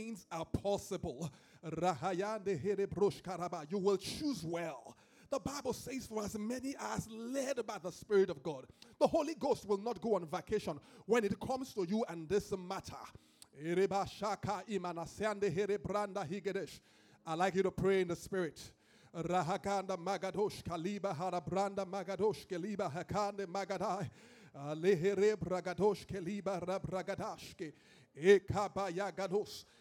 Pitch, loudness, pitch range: 195 Hz, -38 LUFS, 180-205 Hz